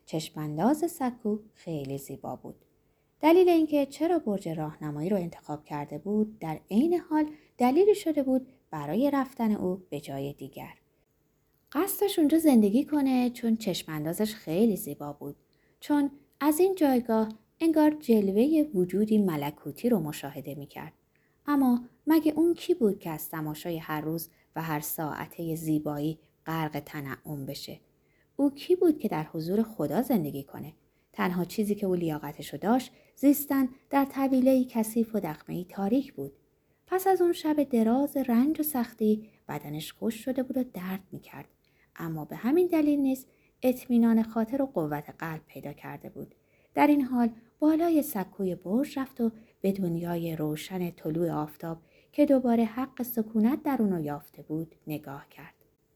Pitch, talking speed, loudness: 215 Hz, 150 wpm, -28 LUFS